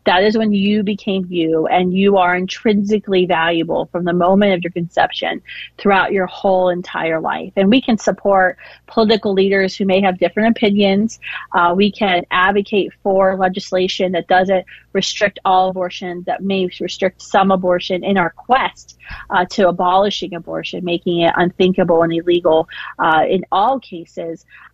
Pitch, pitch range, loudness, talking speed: 185 Hz, 175-200 Hz, -16 LUFS, 160 wpm